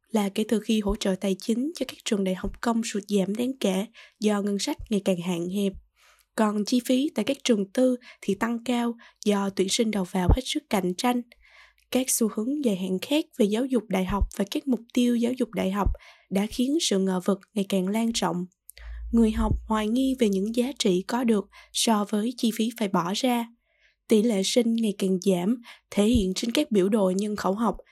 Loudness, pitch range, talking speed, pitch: -26 LUFS, 195-245 Hz, 225 wpm, 220 Hz